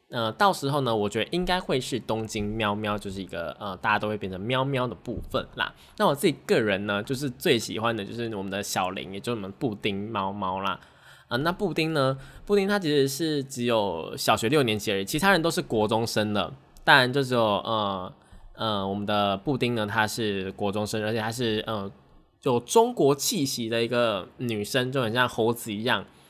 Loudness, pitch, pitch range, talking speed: -26 LUFS, 110 Hz, 105-130 Hz, 305 characters per minute